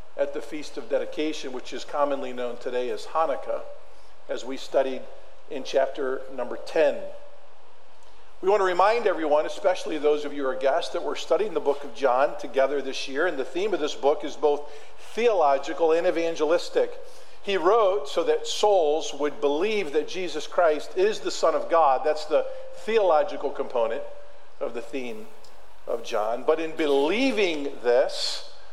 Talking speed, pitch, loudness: 165 wpm, 185 Hz, -25 LUFS